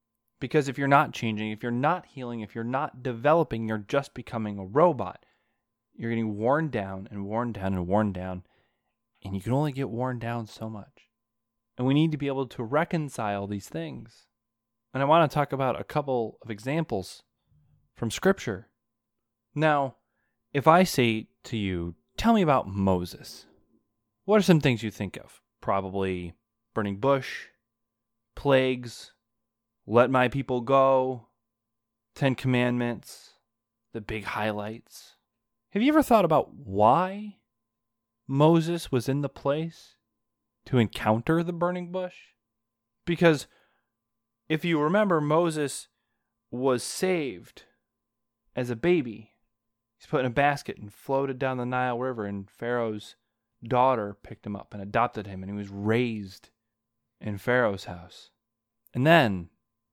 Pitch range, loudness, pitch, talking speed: 110-135 Hz, -27 LUFS, 115 Hz, 145 wpm